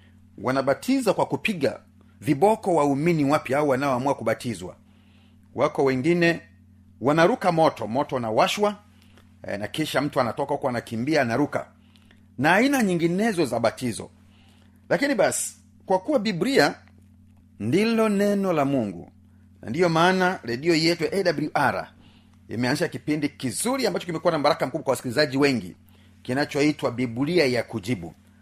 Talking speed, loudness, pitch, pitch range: 130 wpm, -23 LUFS, 135 Hz, 105-170 Hz